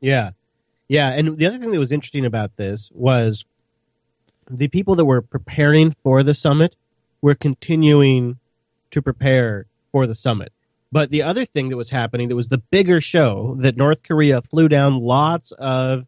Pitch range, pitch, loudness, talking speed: 120-150 Hz, 135 Hz, -18 LUFS, 170 wpm